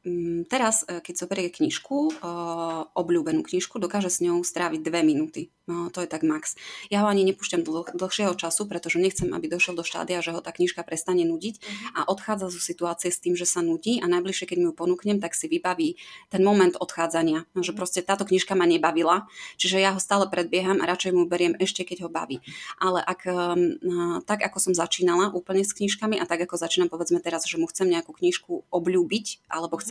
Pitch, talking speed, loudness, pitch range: 180 Hz, 205 wpm, -25 LUFS, 170-200 Hz